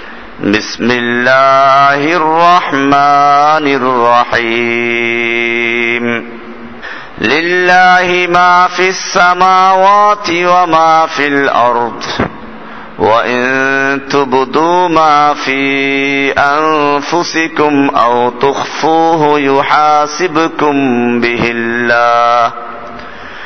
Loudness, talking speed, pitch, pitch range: -9 LUFS, 55 wpm, 140 Hz, 120-160 Hz